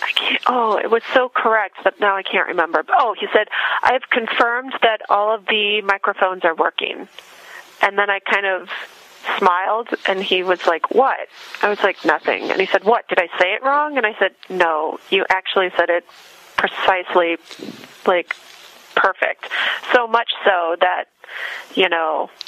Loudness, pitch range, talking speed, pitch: -18 LUFS, 185-225 Hz, 175 wpm, 200 Hz